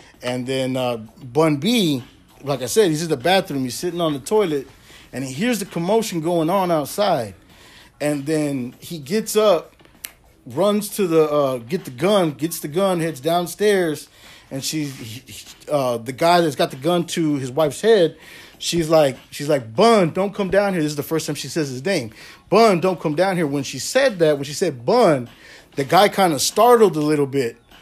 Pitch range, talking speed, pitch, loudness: 135-185 Hz, 205 wpm, 160 Hz, -19 LUFS